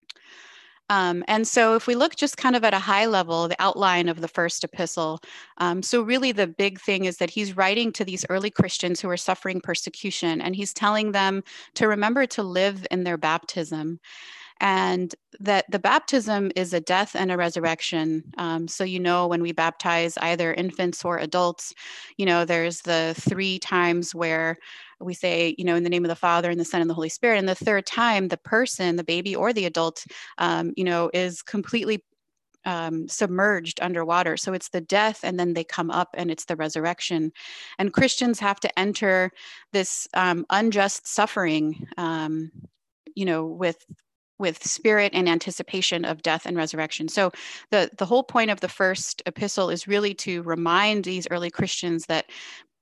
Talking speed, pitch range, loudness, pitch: 185 wpm, 170-200 Hz, -24 LUFS, 180 Hz